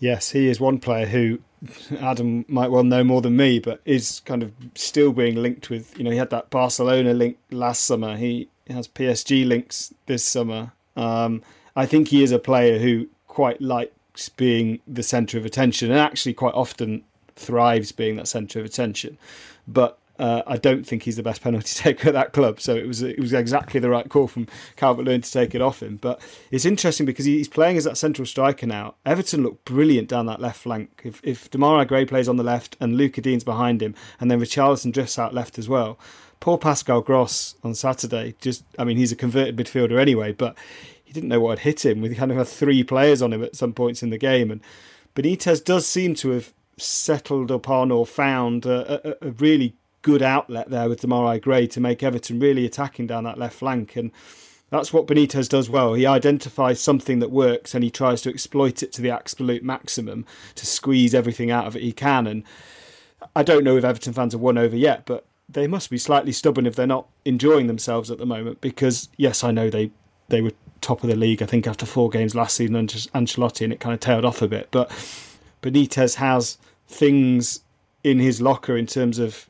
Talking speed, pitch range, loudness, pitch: 220 wpm, 115-135 Hz, -21 LUFS, 125 Hz